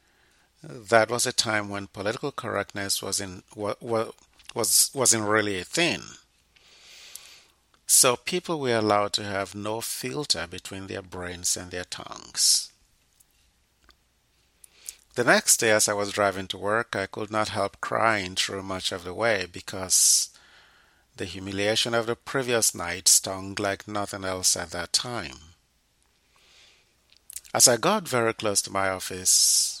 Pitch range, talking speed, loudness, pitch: 95-110 Hz, 140 wpm, -24 LUFS, 100 Hz